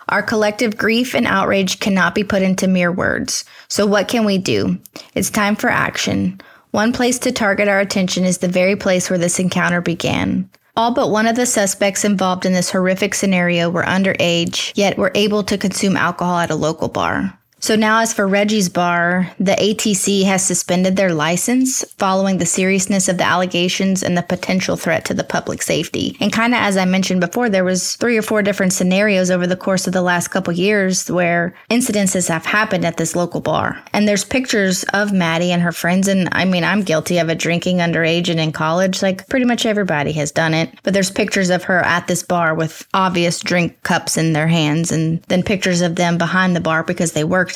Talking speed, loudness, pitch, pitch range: 210 wpm, -16 LUFS, 185 Hz, 175-205 Hz